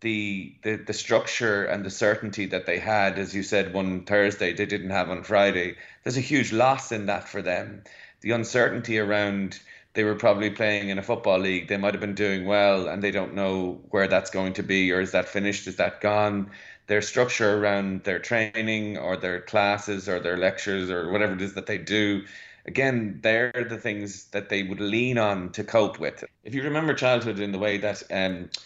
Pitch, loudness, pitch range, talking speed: 100 Hz, -25 LUFS, 95-110 Hz, 205 wpm